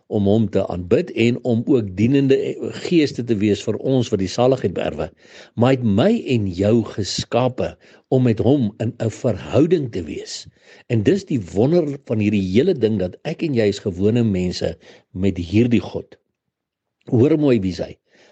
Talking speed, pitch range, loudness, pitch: 180 wpm, 100-130 Hz, -19 LUFS, 115 Hz